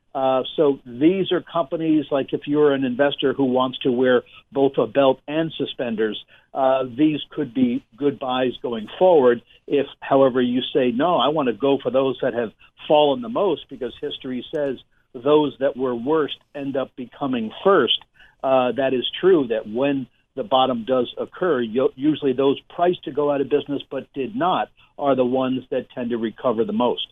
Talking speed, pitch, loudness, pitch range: 185 wpm, 135 Hz, -21 LUFS, 130-145 Hz